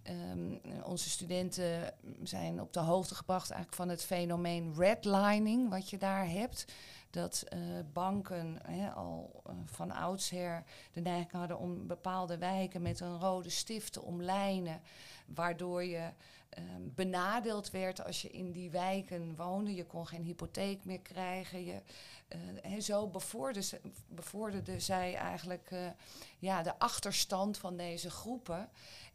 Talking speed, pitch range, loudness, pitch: 140 wpm, 170-190 Hz, -38 LUFS, 180 Hz